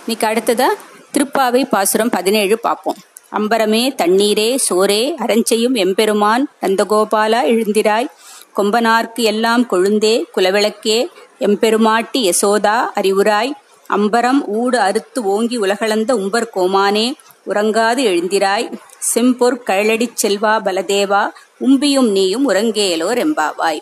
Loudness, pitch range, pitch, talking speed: -15 LUFS, 205-240 Hz, 220 Hz, 90 wpm